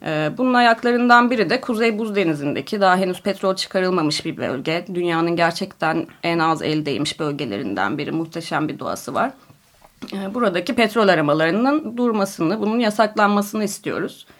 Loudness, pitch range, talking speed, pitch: -20 LUFS, 160-220 Hz, 130 wpm, 190 Hz